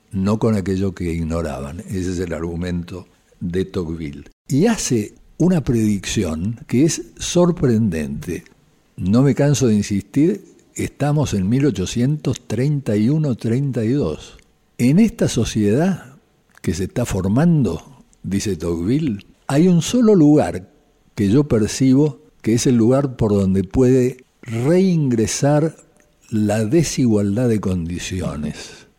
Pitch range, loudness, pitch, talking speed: 95-140 Hz, -18 LUFS, 115 Hz, 110 wpm